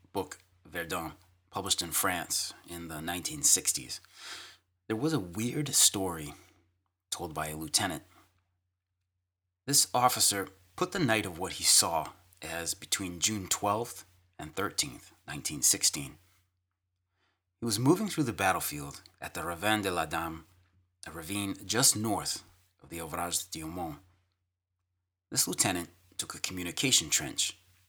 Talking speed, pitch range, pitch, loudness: 130 wpm, 85-100 Hz, 90 Hz, -29 LUFS